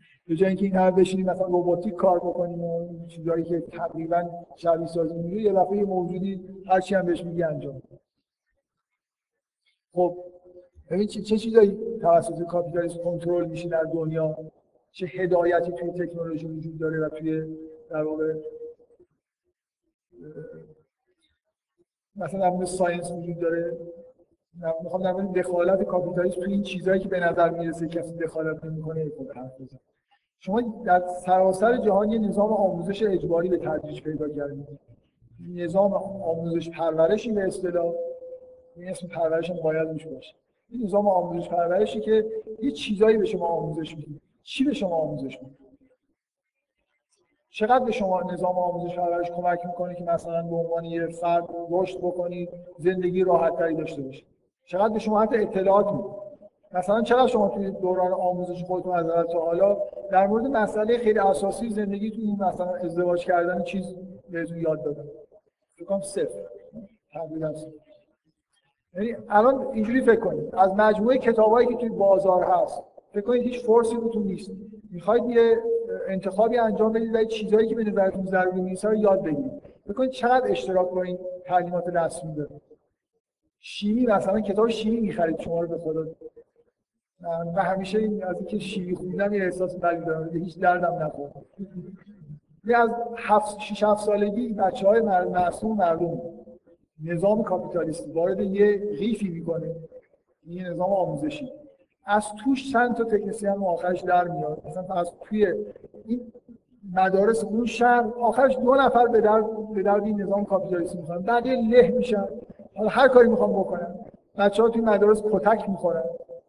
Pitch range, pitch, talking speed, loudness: 170-215 Hz, 185 Hz, 145 wpm, -24 LUFS